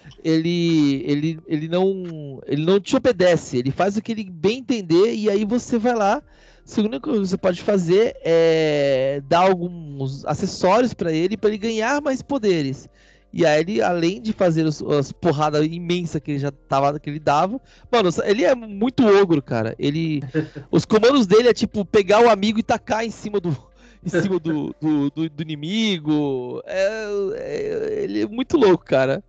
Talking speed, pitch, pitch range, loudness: 180 wpm, 180 Hz, 155-220 Hz, -20 LUFS